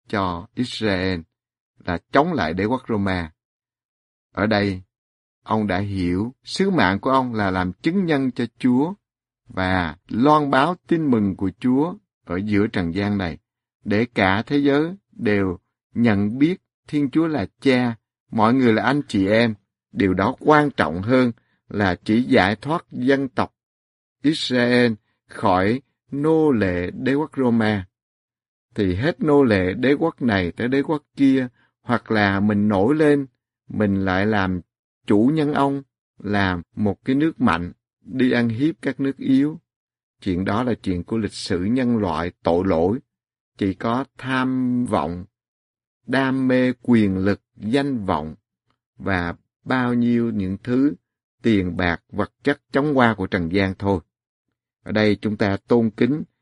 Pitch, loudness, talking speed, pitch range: 115 Hz, -21 LUFS, 155 wpm, 95-130 Hz